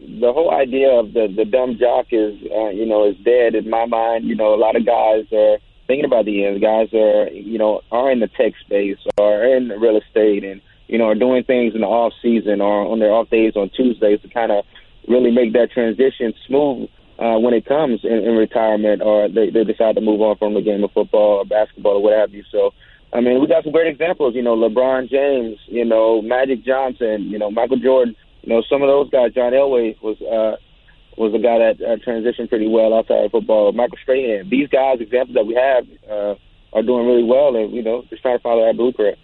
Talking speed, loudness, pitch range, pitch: 240 wpm, -17 LUFS, 105-125 Hz, 115 Hz